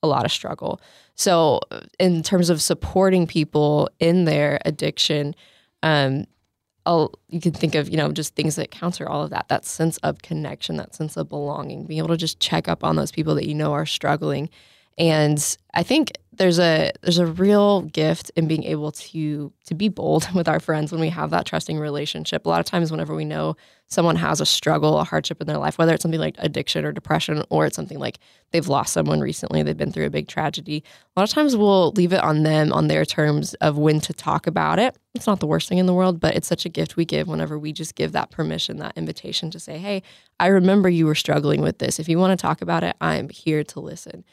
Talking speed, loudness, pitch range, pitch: 235 wpm, -21 LUFS, 150-175 Hz, 160 Hz